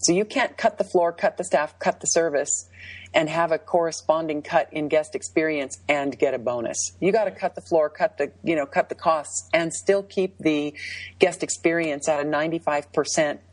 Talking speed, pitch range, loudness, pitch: 200 wpm, 145-170 Hz, -24 LUFS, 155 Hz